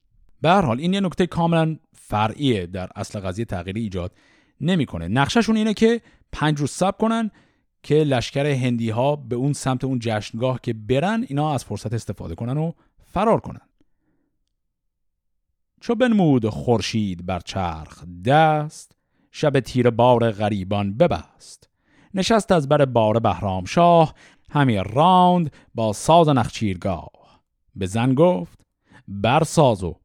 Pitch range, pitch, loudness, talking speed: 100-155 Hz, 120 Hz, -21 LUFS, 135 wpm